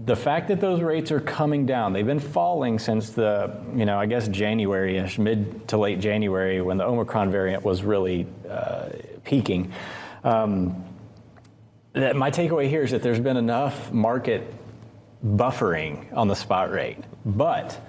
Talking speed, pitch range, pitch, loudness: 160 wpm, 100-125 Hz, 110 Hz, -24 LUFS